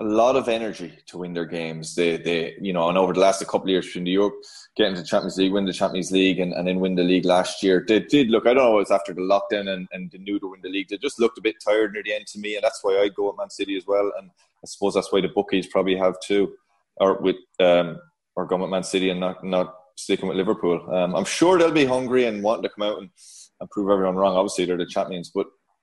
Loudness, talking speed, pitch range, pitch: -22 LUFS, 285 wpm, 90-100 Hz, 95 Hz